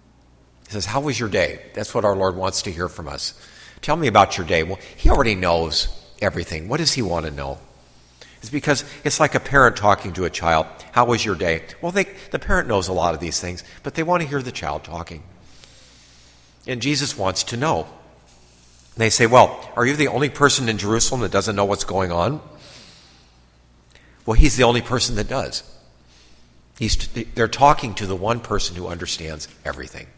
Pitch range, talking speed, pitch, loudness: 80-120 Hz, 205 wpm, 95 Hz, -20 LUFS